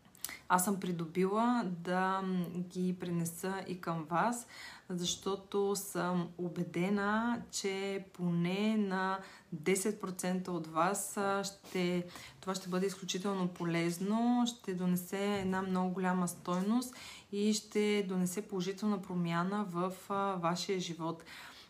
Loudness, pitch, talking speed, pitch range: -35 LUFS, 185 Hz, 110 wpm, 180-200 Hz